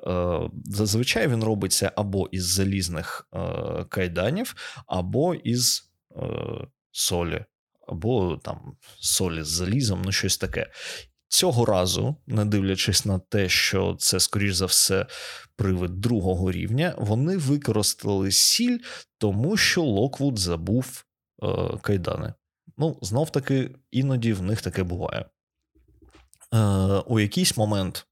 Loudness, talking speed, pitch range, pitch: -24 LUFS, 115 wpm, 95-125 Hz, 105 Hz